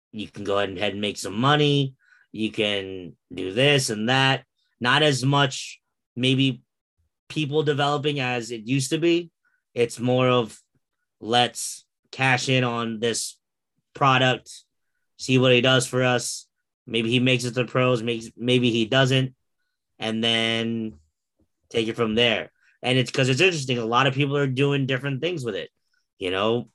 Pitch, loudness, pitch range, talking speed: 125 Hz, -22 LUFS, 115-135 Hz, 165 wpm